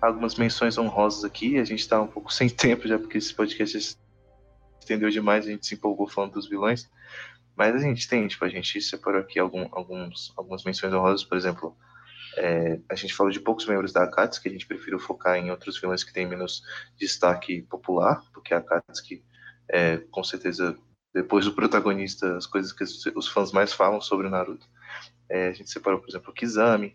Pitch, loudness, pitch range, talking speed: 100 Hz, -26 LUFS, 90-110 Hz, 195 wpm